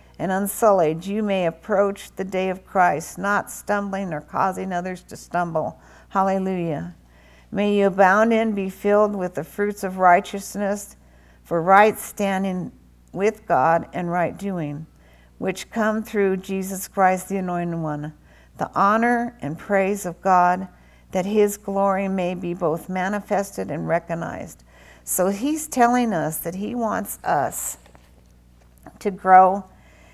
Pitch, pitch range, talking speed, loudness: 185 Hz, 160-200 Hz, 135 wpm, -22 LUFS